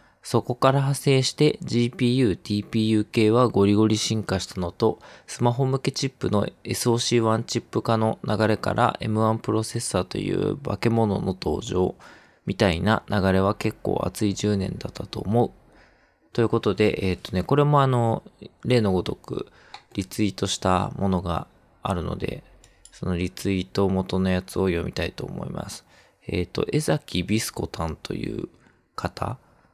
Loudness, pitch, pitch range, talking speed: -24 LUFS, 110 Hz, 95-120 Hz, 310 characters per minute